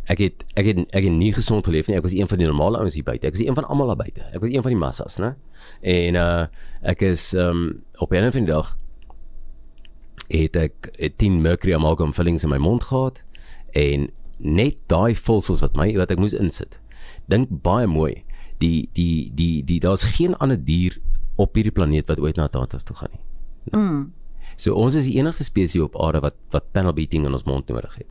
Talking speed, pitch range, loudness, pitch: 220 wpm, 80-110 Hz, -21 LUFS, 90 Hz